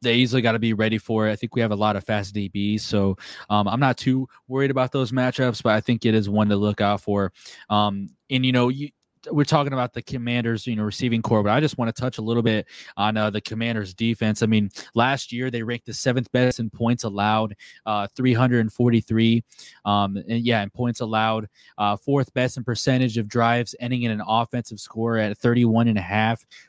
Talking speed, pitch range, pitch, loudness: 225 wpm, 105-125 Hz, 115 Hz, -23 LUFS